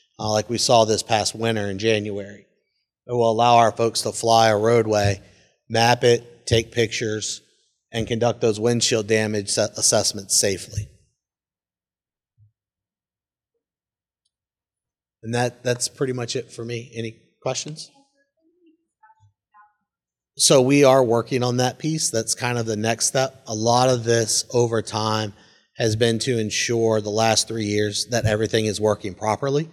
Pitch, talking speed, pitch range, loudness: 115 Hz, 145 wpm, 110-125 Hz, -20 LUFS